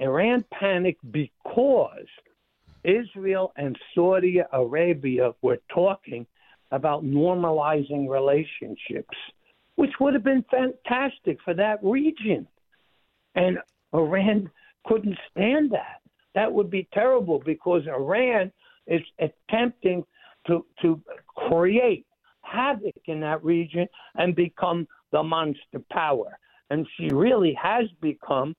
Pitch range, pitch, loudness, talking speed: 155-220 Hz, 180 Hz, -25 LUFS, 105 wpm